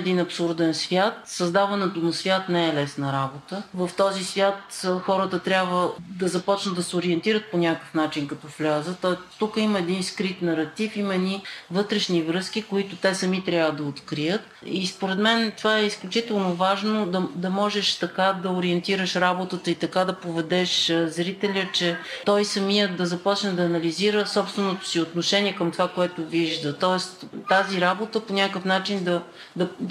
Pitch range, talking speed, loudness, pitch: 175-195 Hz, 165 wpm, -24 LUFS, 185 Hz